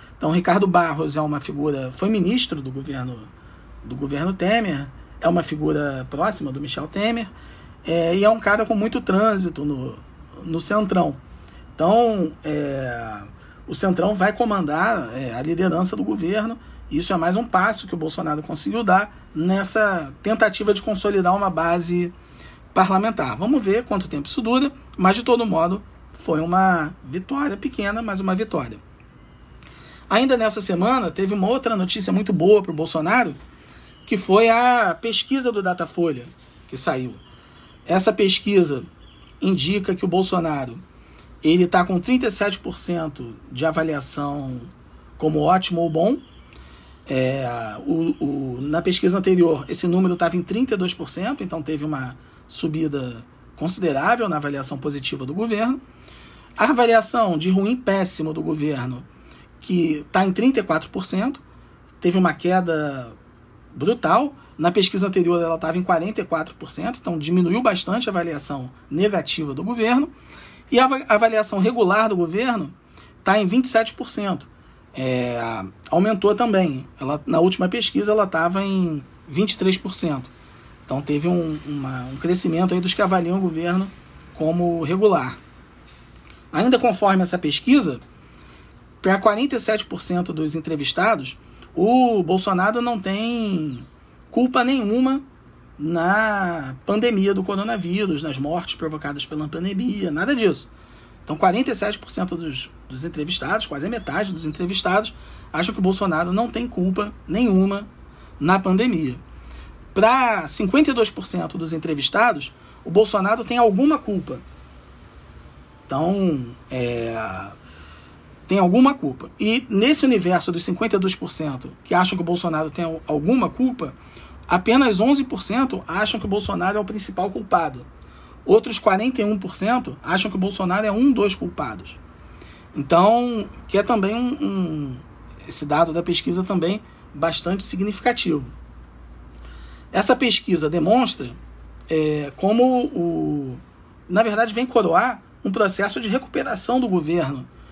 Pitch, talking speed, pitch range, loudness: 180 Hz, 130 wpm, 150-215 Hz, -21 LUFS